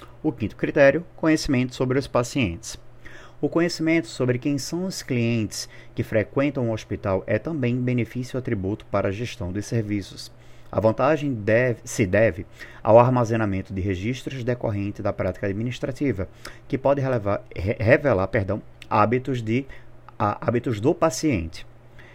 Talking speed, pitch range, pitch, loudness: 135 wpm, 110-135 Hz, 120 Hz, -24 LUFS